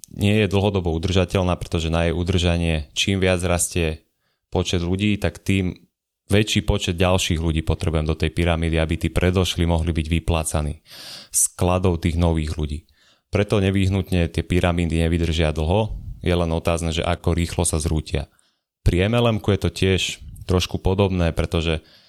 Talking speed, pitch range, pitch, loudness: 150 wpm, 80-95 Hz, 85 Hz, -21 LUFS